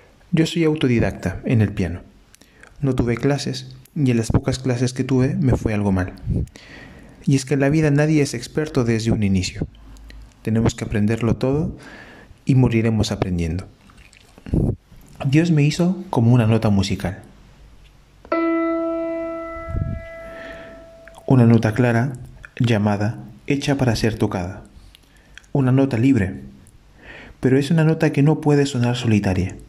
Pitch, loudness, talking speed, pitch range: 125 Hz, -20 LUFS, 135 wpm, 105-145 Hz